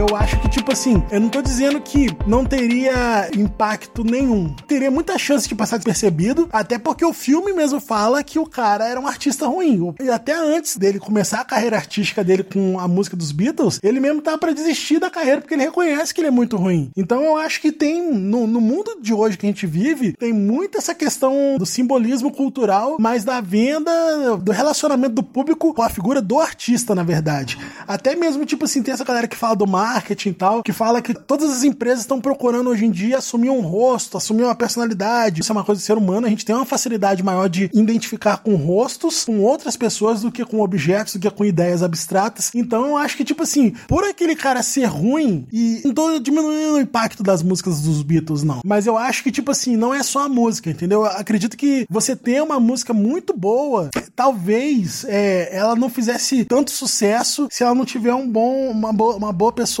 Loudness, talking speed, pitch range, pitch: -18 LUFS, 215 wpm, 210-275 Hz, 235 Hz